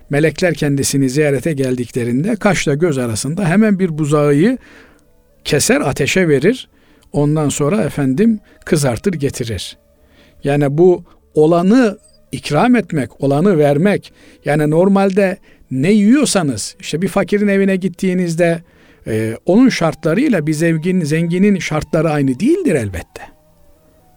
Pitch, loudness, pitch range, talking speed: 160 Hz, -15 LUFS, 145-195 Hz, 105 wpm